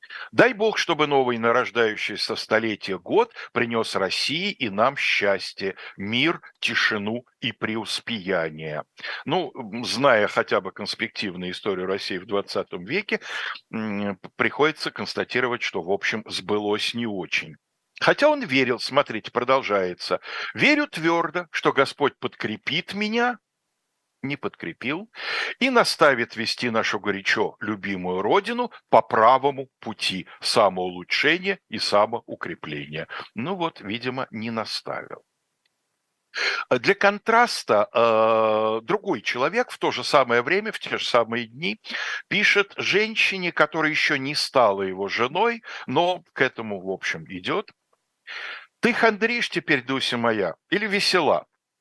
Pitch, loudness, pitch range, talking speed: 125 Hz, -23 LUFS, 105-180 Hz, 115 wpm